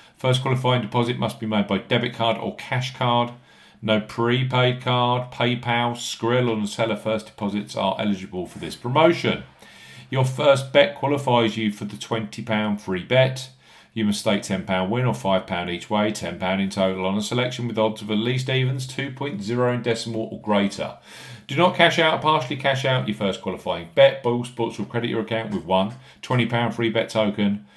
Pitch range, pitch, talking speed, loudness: 105-125 Hz, 115 Hz, 185 wpm, -23 LUFS